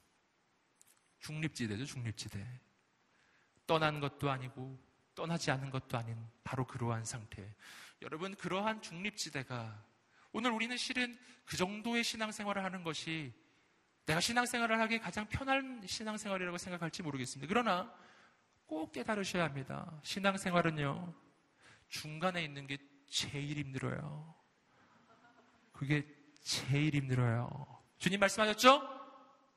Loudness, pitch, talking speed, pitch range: -37 LUFS, 160 Hz, 280 characters per minute, 130-210 Hz